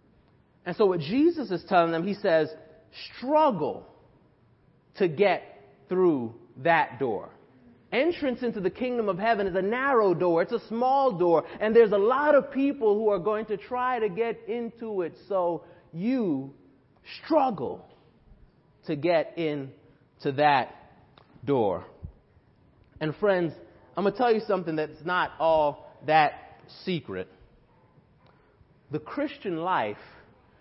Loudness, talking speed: -26 LUFS, 135 wpm